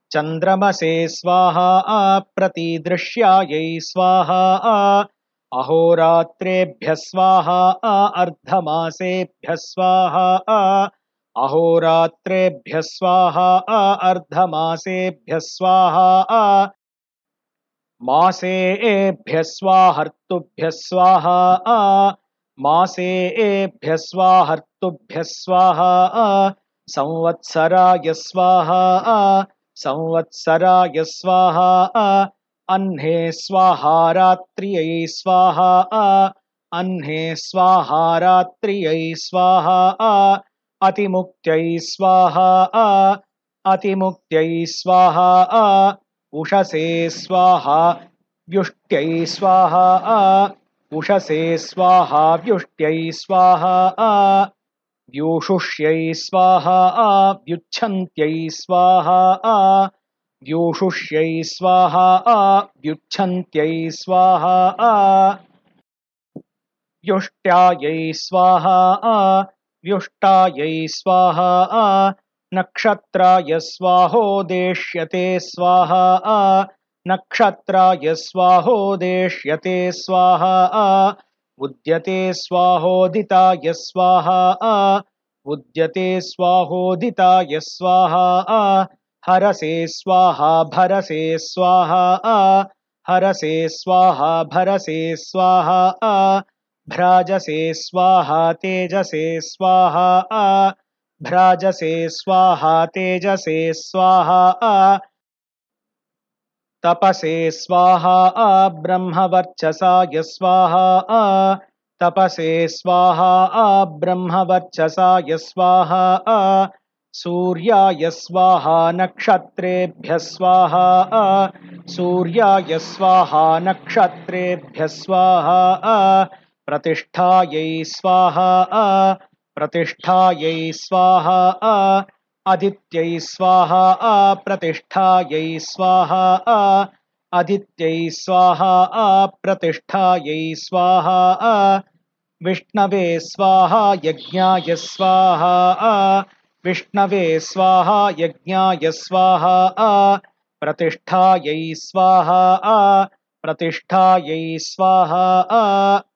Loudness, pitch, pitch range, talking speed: -15 LUFS, 185 Hz, 165-190 Hz, 55 wpm